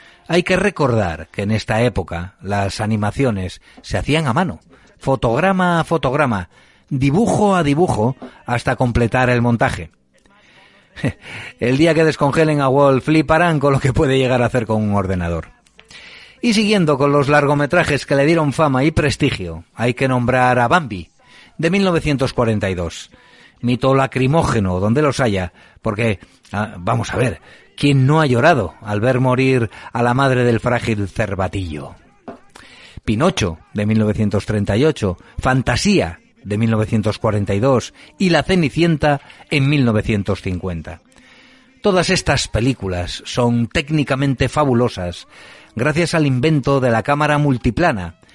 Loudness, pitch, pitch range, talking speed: -17 LUFS, 125 Hz, 105-145 Hz, 130 wpm